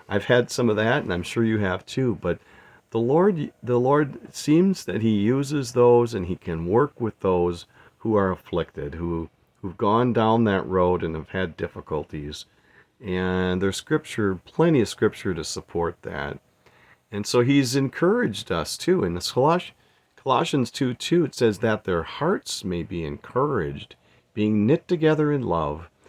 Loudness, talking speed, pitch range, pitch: -23 LUFS, 170 wpm, 85-125 Hz, 105 Hz